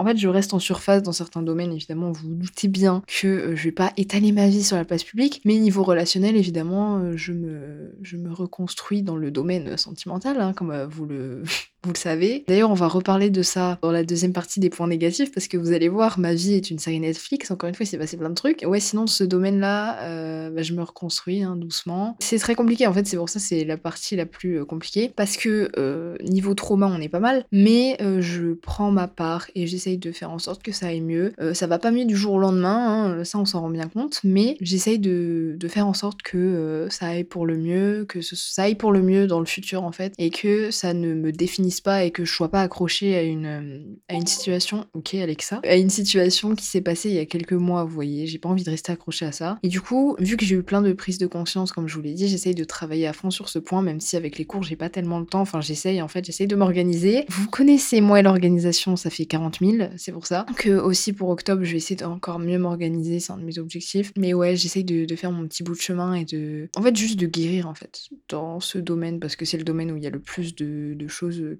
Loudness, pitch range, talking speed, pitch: -23 LUFS, 165-195 Hz, 270 wpm, 180 Hz